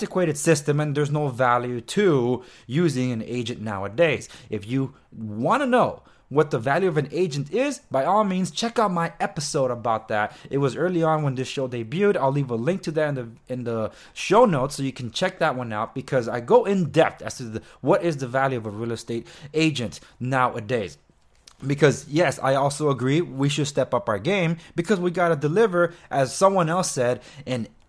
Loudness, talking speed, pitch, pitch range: -23 LUFS, 210 wpm, 140 Hz, 125-170 Hz